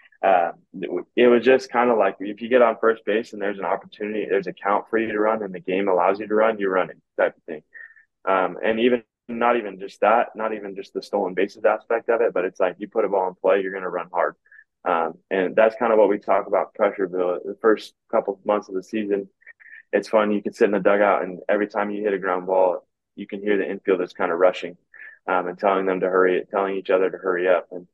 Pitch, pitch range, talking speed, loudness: 105 Hz, 95-115 Hz, 260 wpm, -22 LUFS